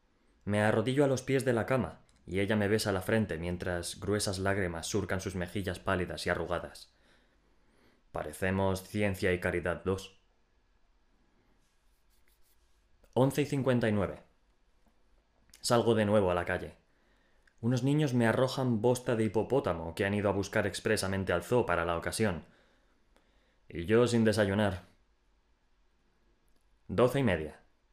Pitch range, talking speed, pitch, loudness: 90-110 Hz, 135 wpm, 100 Hz, -31 LUFS